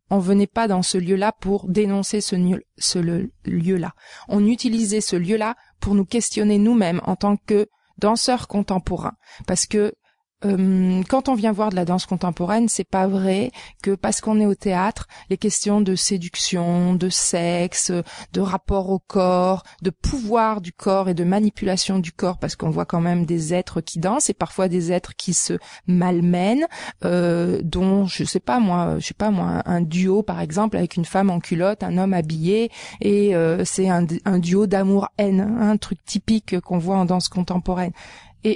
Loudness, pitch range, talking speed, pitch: -21 LUFS, 180-210 Hz, 185 wpm, 190 Hz